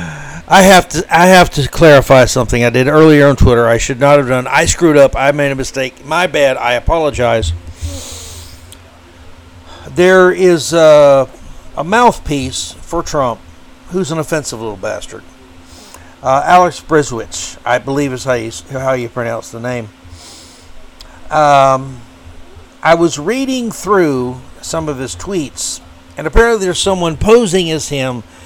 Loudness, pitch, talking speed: -11 LUFS, 130 Hz, 150 wpm